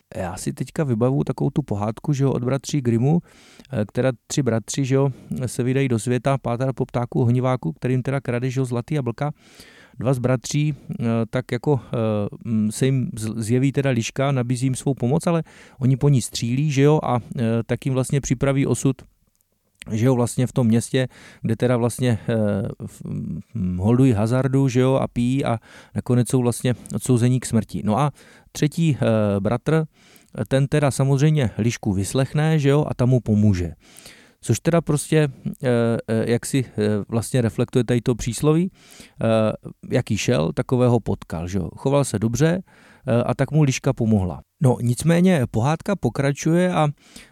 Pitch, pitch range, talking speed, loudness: 125 Hz, 115-140 Hz, 165 wpm, -21 LUFS